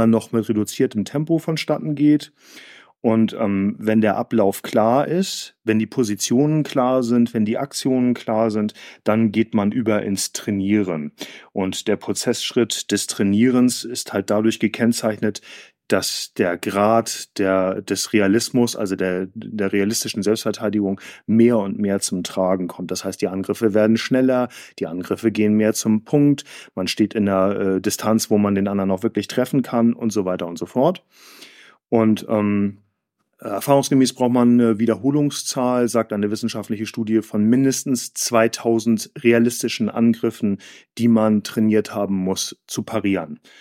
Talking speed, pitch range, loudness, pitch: 150 wpm, 105-120 Hz, -20 LUFS, 110 Hz